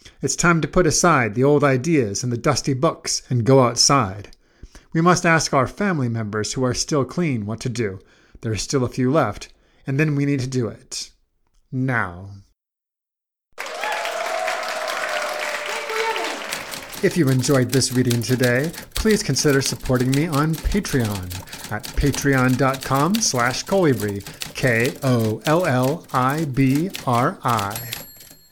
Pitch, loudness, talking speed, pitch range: 135 Hz, -20 LUFS, 125 wpm, 120-155 Hz